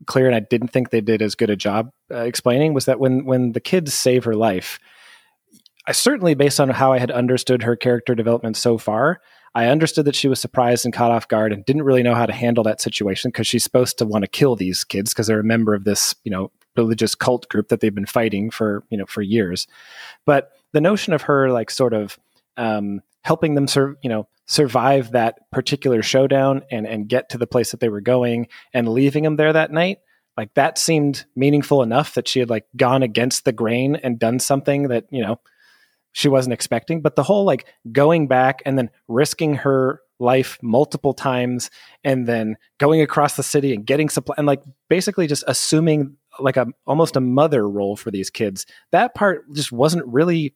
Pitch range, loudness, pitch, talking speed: 115-145 Hz, -19 LUFS, 125 Hz, 215 wpm